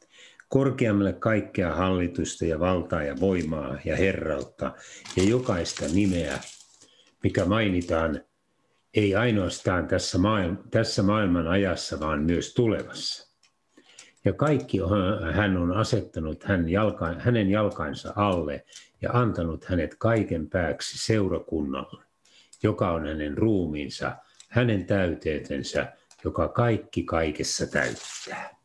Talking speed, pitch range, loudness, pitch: 105 wpm, 85-105 Hz, -26 LUFS, 95 Hz